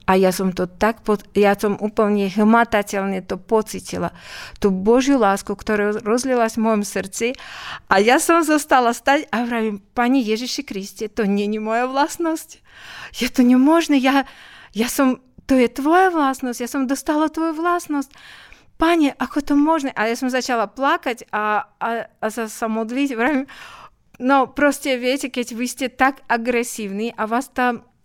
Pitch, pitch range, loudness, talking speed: 245 Hz, 215-275 Hz, -19 LUFS, 165 wpm